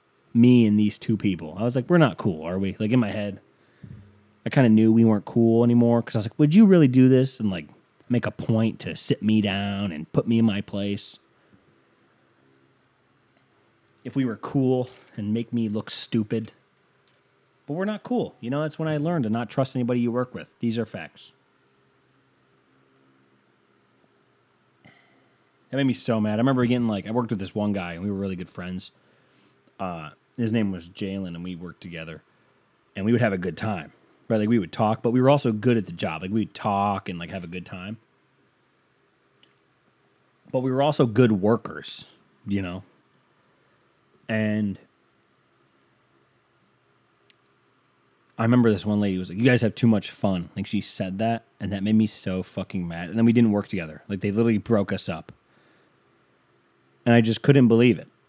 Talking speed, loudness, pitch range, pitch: 195 wpm, -23 LUFS, 75-115 Hz, 105 Hz